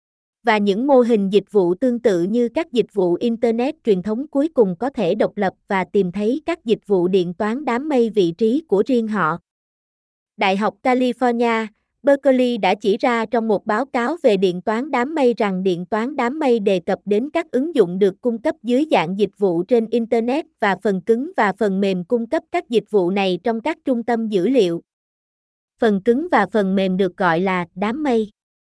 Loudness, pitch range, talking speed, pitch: -19 LUFS, 195-250 Hz, 210 wpm, 225 Hz